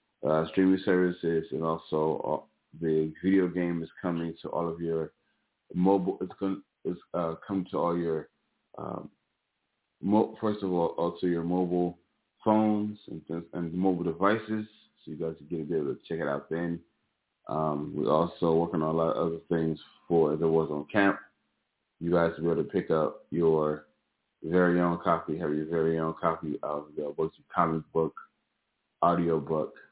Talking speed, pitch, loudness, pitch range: 180 wpm, 85 Hz, -29 LUFS, 80-90 Hz